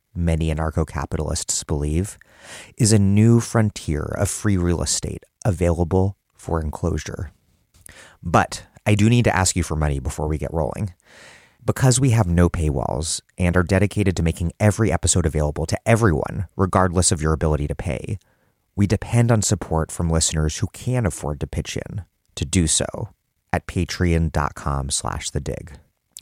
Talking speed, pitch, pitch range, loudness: 155 wpm, 90 Hz, 80-105 Hz, -21 LUFS